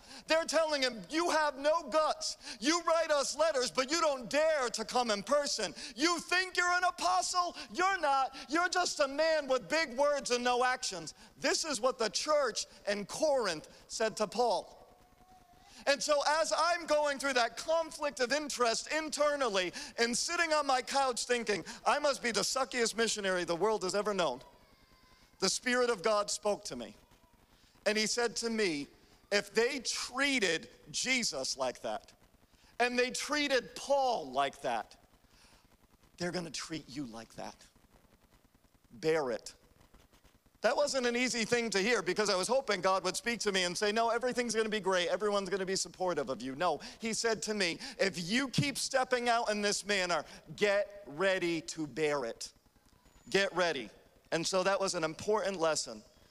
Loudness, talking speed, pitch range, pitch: -32 LUFS, 175 wpm, 195-290 Hz, 235 Hz